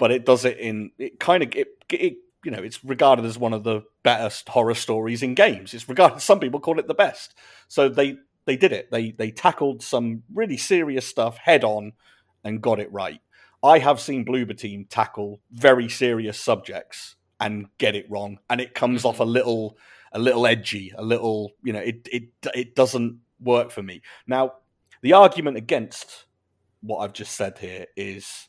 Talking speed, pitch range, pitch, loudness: 195 wpm, 110-135 Hz, 120 Hz, -22 LUFS